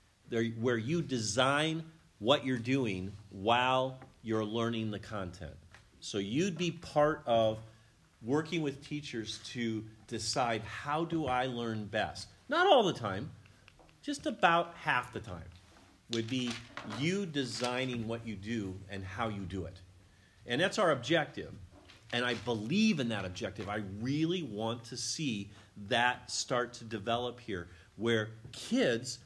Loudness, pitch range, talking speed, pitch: -34 LUFS, 105-130 Hz, 140 wpm, 115 Hz